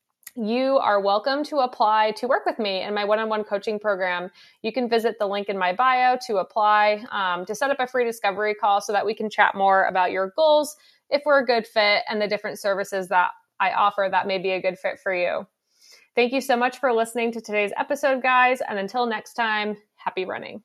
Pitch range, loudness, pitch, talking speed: 200-255 Hz, -22 LUFS, 215 Hz, 230 wpm